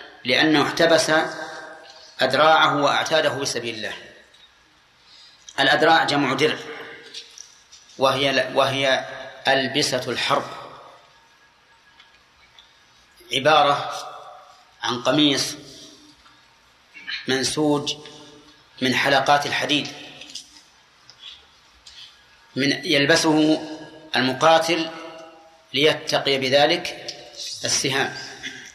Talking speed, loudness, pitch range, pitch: 55 wpm, -20 LUFS, 135-155 Hz, 150 Hz